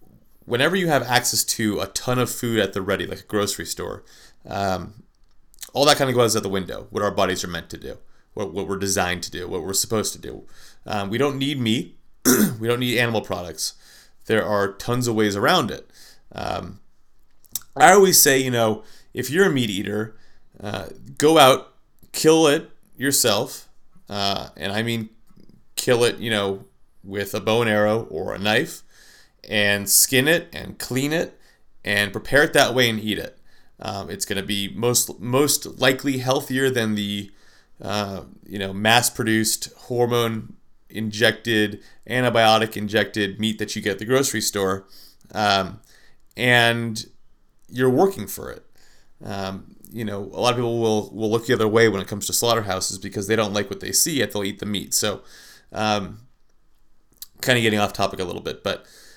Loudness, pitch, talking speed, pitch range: -21 LUFS, 110 Hz, 185 wpm, 100-120 Hz